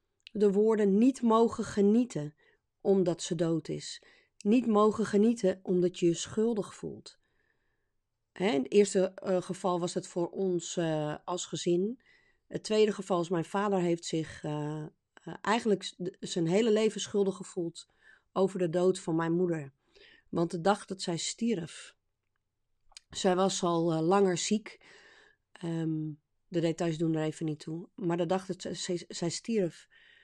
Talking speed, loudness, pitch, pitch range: 145 wpm, -30 LUFS, 185 Hz, 170-210 Hz